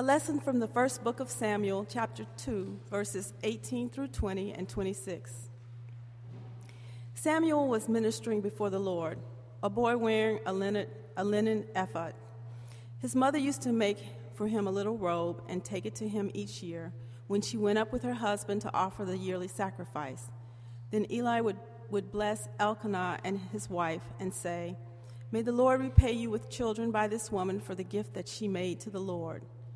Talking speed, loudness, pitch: 180 wpm, -33 LUFS, 185 Hz